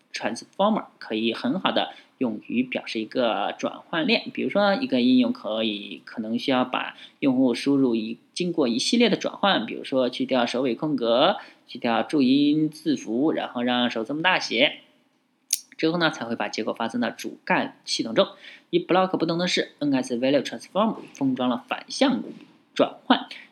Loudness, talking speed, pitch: -24 LUFS, 320 characters per minute, 165 Hz